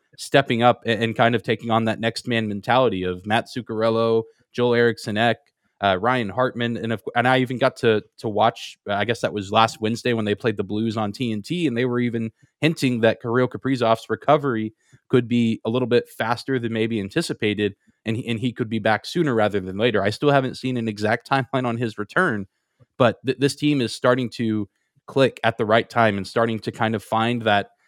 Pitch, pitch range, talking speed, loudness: 115 Hz, 110-125 Hz, 215 wpm, -22 LUFS